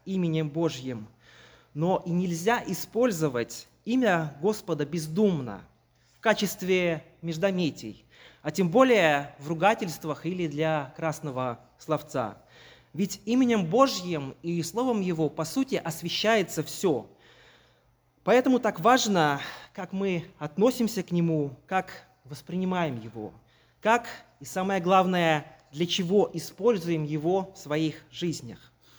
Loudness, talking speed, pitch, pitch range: -27 LUFS, 110 wpm, 170 Hz, 150-195 Hz